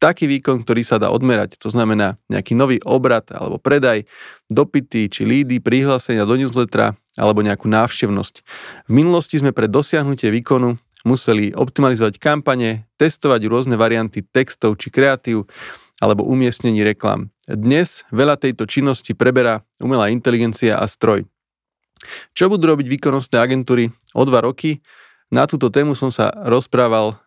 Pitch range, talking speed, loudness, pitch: 110-135 Hz, 140 wpm, -17 LUFS, 125 Hz